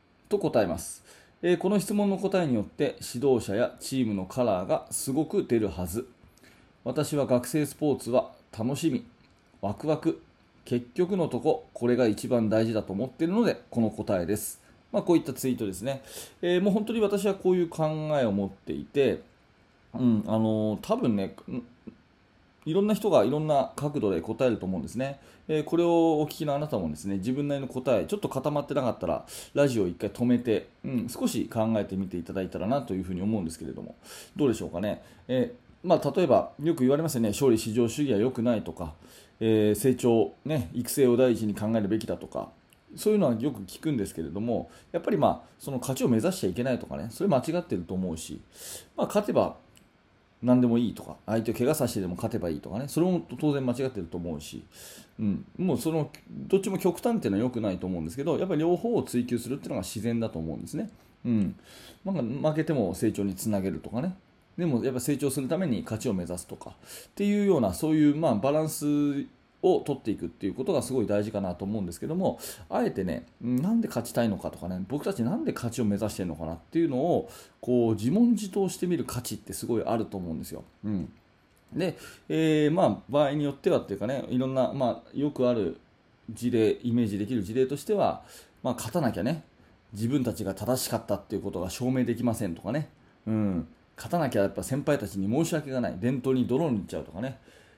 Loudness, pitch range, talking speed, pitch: -28 LUFS, 105-150 Hz, 425 characters per minute, 125 Hz